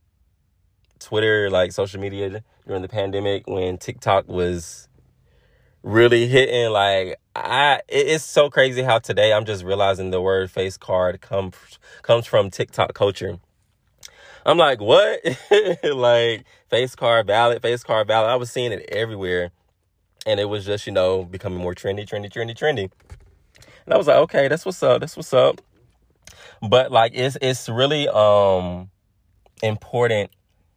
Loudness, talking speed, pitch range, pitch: -20 LUFS, 150 wpm, 95-120 Hz, 100 Hz